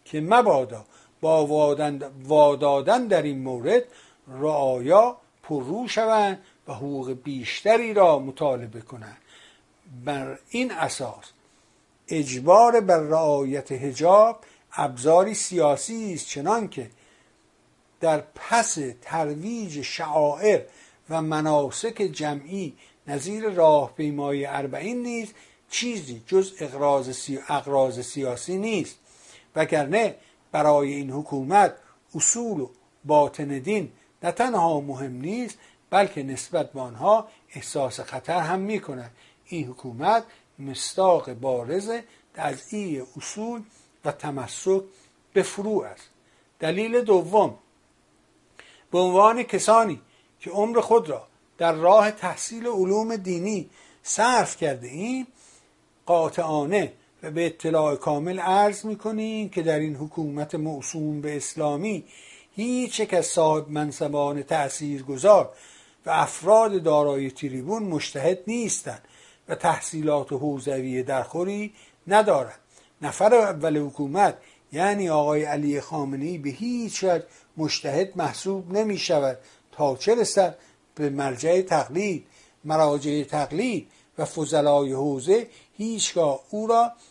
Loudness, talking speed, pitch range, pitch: -24 LUFS, 105 wpm, 145-205 Hz, 160 Hz